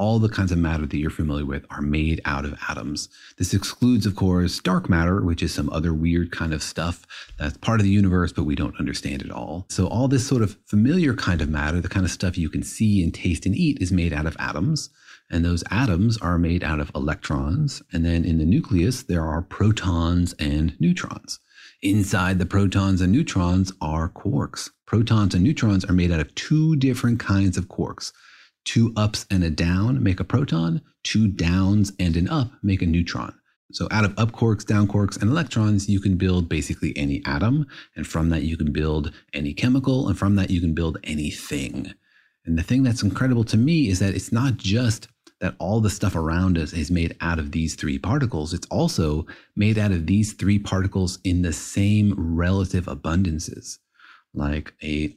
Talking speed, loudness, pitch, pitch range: 205 wpm, -23 LUFS, 95 Hz, 80-105 Hz